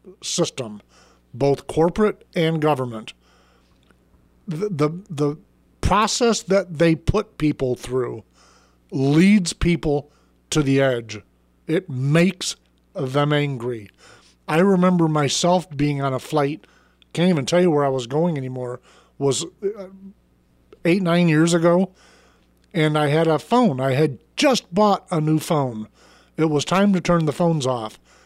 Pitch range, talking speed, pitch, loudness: 130-175 Hz, 135 wpm, 150 Hz, -20 LUFS